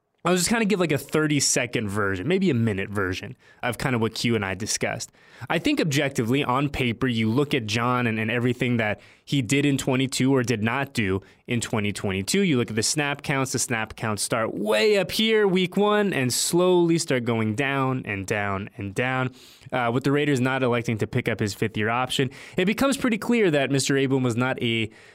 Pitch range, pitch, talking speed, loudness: 110-145 Hz, 130 Hz, 215 wpm, -24 LUFS